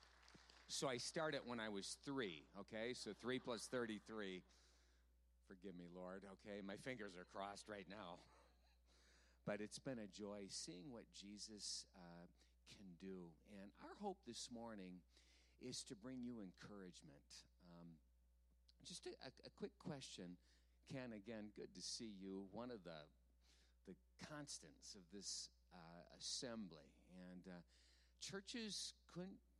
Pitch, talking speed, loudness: 95 Hz, 140 wpm, -53 LUFS